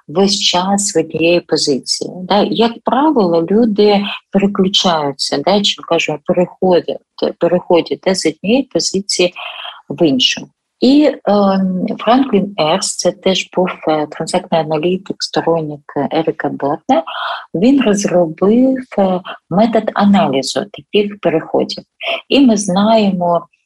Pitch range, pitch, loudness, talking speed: 170-210 Hz, 190 Hz, -14 LUFS, 100 wpm